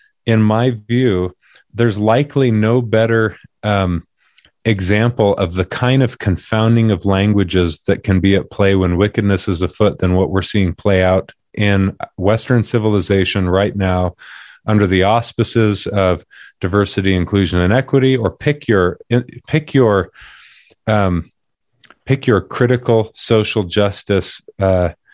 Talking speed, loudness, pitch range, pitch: 135 wpm, -15 LUFS, 95-115 Hz, 105 Hz